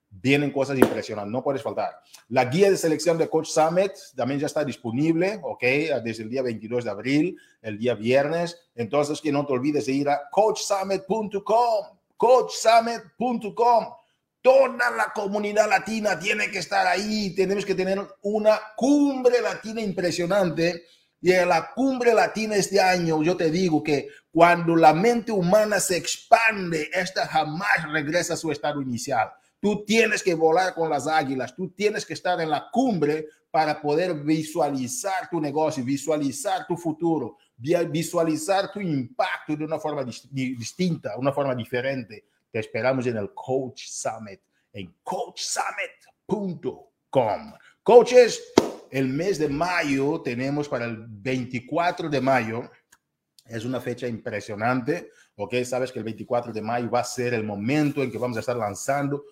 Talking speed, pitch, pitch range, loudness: 150 wpm, 160 Hz, 135-195 Hz, -24 LUFS